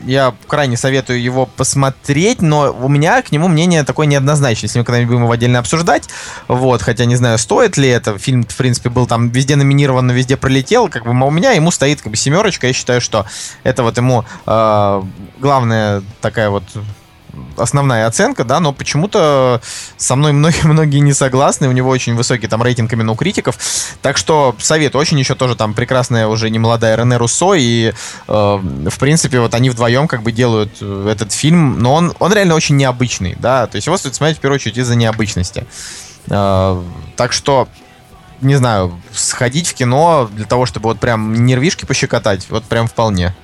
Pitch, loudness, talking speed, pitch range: 125 Hz, -13 LUFS, 185 wpm, 110-140 Hz